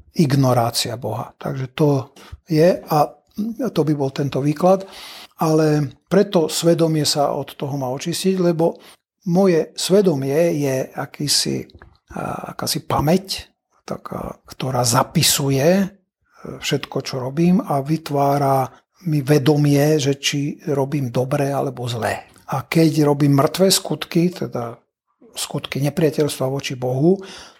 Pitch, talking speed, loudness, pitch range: 150 Hz, 115 wpm, -19 LUFS, 135-170 Hz